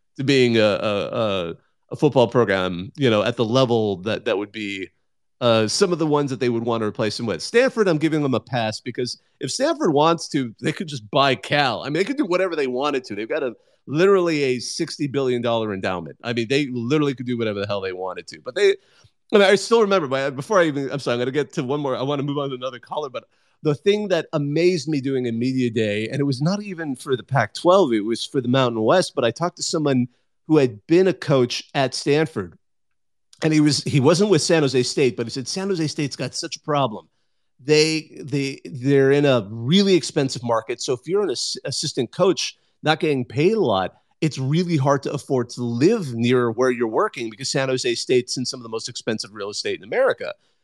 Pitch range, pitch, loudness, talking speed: 125-160 Hz, 140 Hz, -21 LUFS, 240 wpm